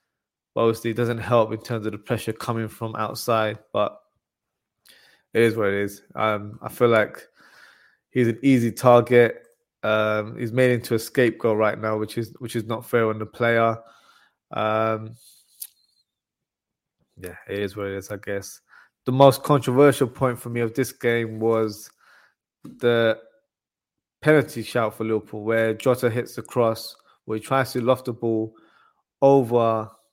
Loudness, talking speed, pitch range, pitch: -22 LUFS, 160 wpm, 110-120 Hz, 115 Hz